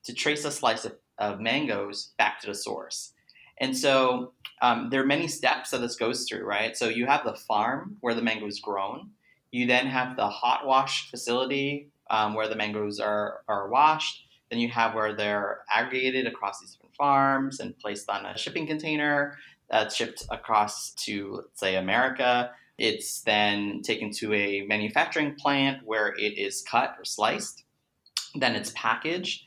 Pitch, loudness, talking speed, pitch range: 125 Hz, -27 LUFS, 175 wpm, 105-140 Hz